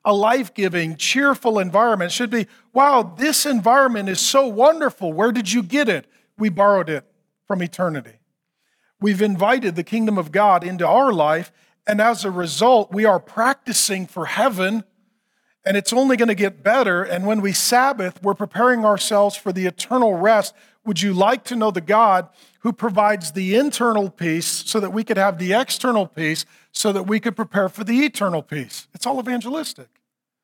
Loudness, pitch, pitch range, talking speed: -19 LUFS, 210 Hz, 185-235 Hz, 180 wpm